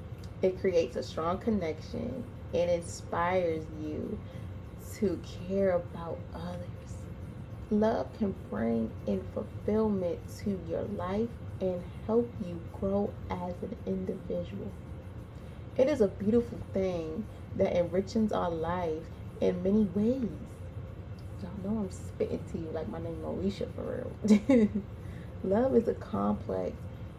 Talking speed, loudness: 120 wpm, -32 LUFS